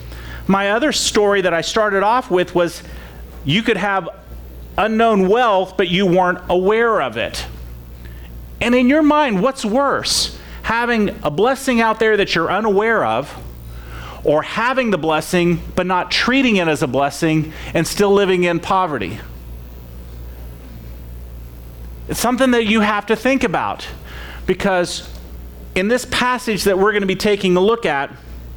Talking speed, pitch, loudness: 150 wpm, 180 Hz, -16 LUFS